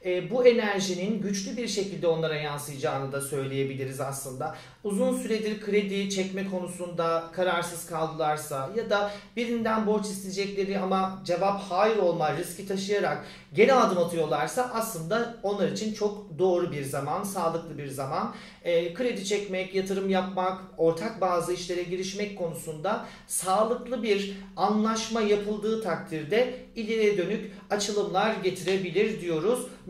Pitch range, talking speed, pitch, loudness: 170-210 Hz, 120 wpm, 190 Hz, -28 LUFS